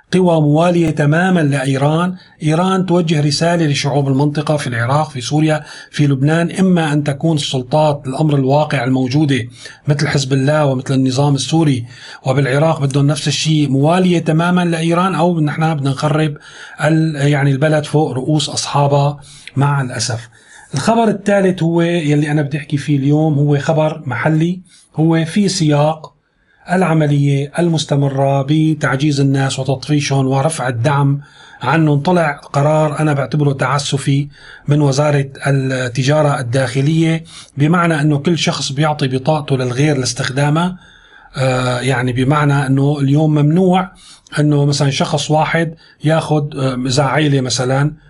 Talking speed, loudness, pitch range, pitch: 120 wpm, -15 LUFS, 140-160 Hz, 150 Hz